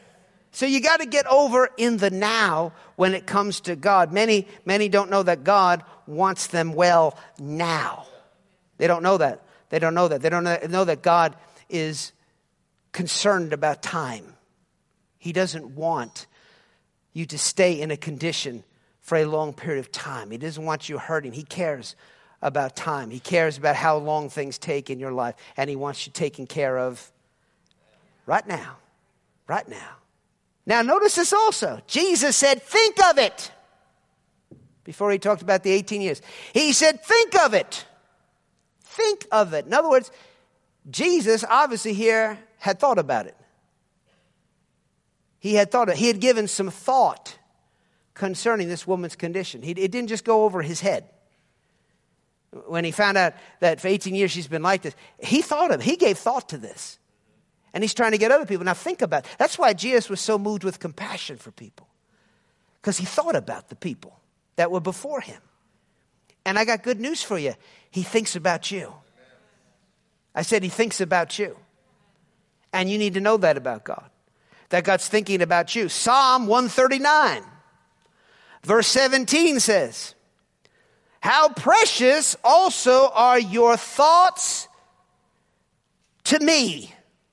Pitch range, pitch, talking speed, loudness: 165-235 Hz, 195 Hz, 160 wpm, -21 LUFS